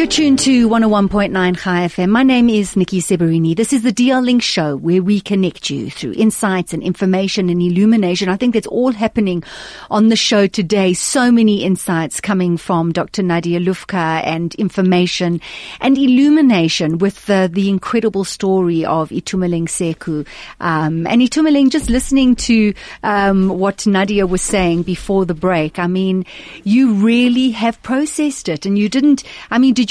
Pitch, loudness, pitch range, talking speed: 195 Hz, -15 LUFS, 180-230 Hz, 165 wpm